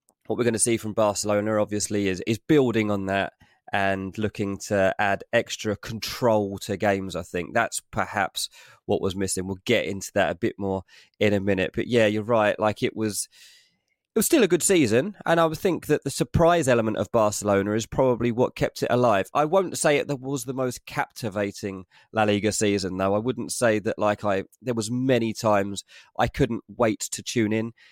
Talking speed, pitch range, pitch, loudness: 205 wpm, 100-125 Hz, 105 Hz, -24 LUFS